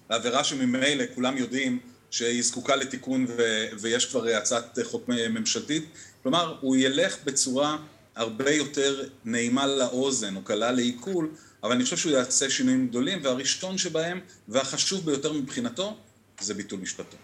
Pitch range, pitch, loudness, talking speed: 125-170 Hz, 135 Hz, -26 LUFS, 135 wpm